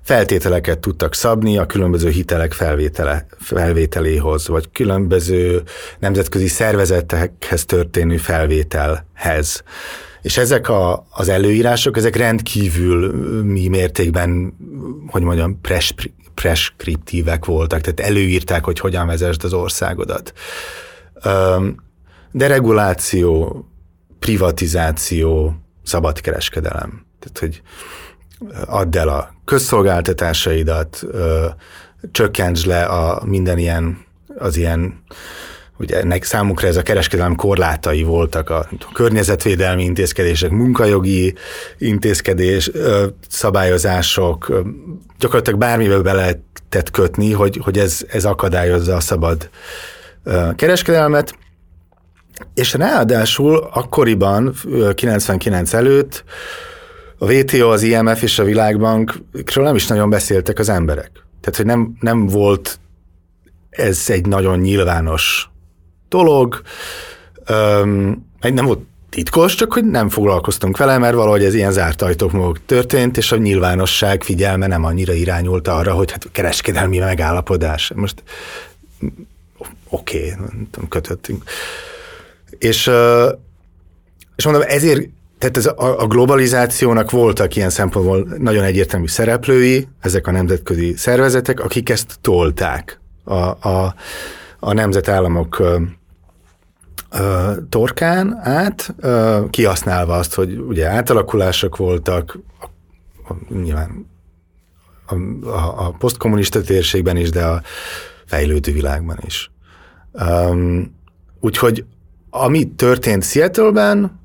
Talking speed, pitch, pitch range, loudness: 100 wpm, 95 Hz, 85-110 Hz, -16 LUFS